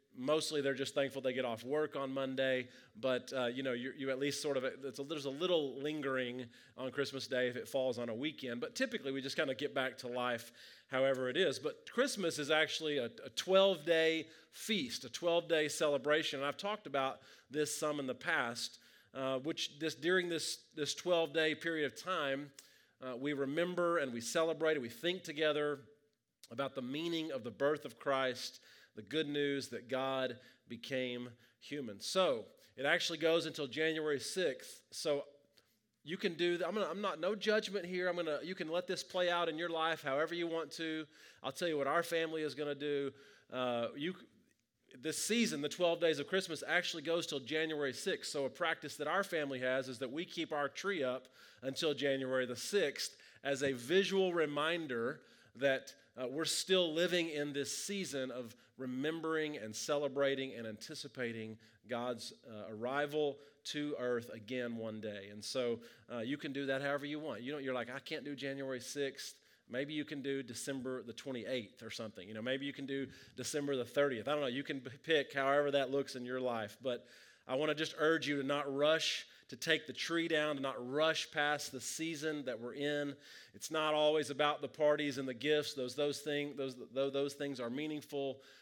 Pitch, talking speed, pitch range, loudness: 145 Hz, 200 wpm, 130-160 Hz, -37 LUFS